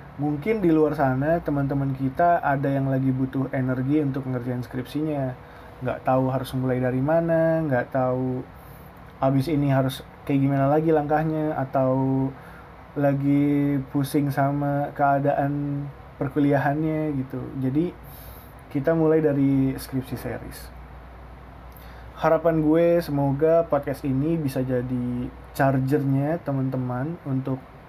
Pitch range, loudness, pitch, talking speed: 130-150 Hz, -24 LUFS, 140 Hz, 110 wpm